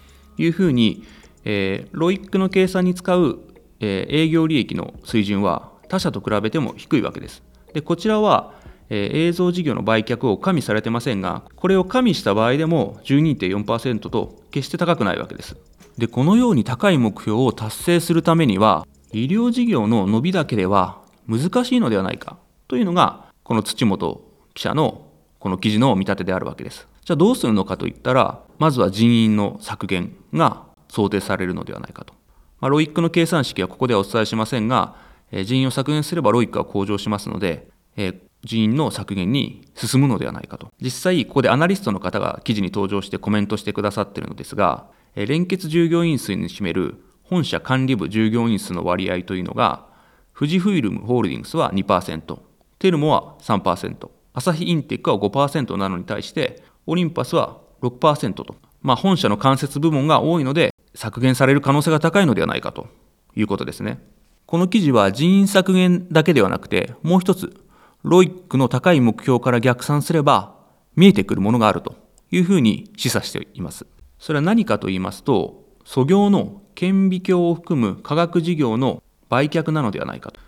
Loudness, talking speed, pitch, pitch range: -19 LUFS, 360 characters per minute, 135 Hz, 105-175 Hz